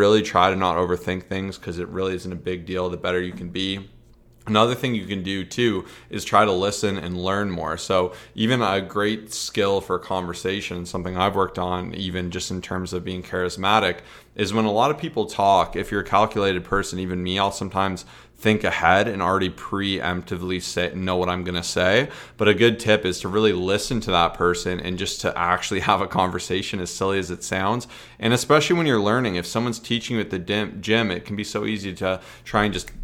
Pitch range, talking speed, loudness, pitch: 90-105 Hz, 220 wpm, -23 LUFS, 95 Hz